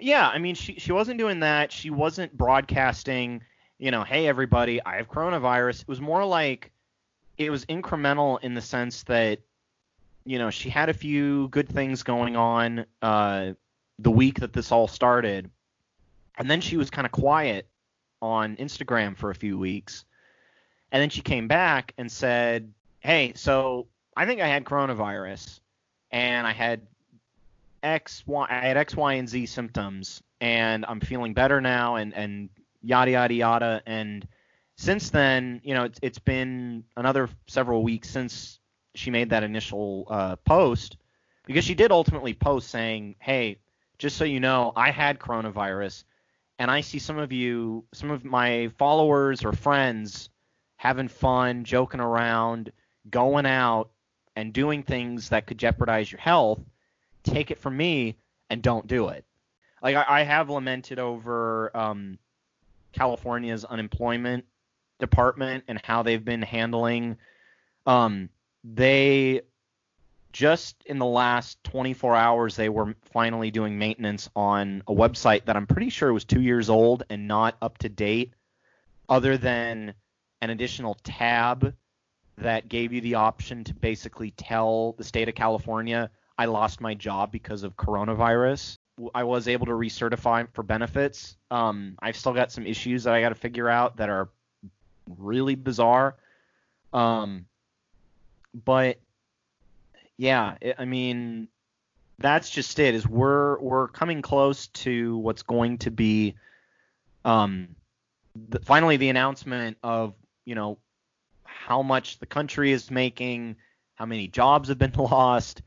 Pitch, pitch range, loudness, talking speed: 120 Hz, 110-130 Hz, -25 LUFS, 150 wpm